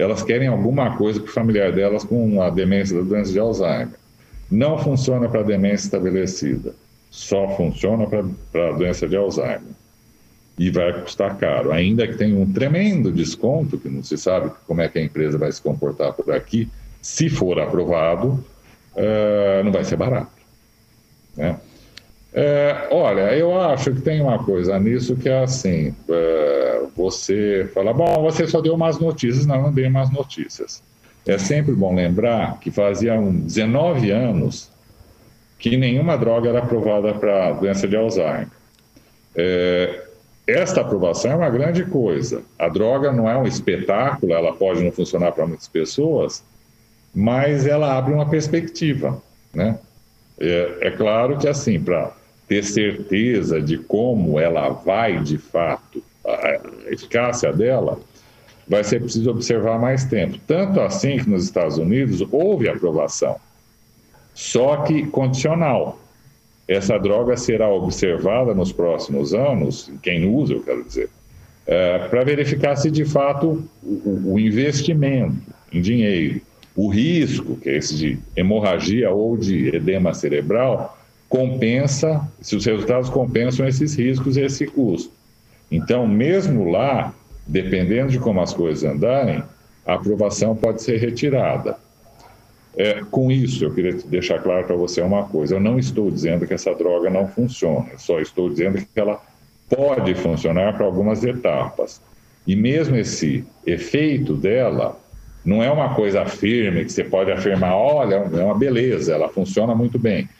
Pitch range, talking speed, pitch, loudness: 100-140 Hz, 150 wpm, 115 Hz, -19 LUFS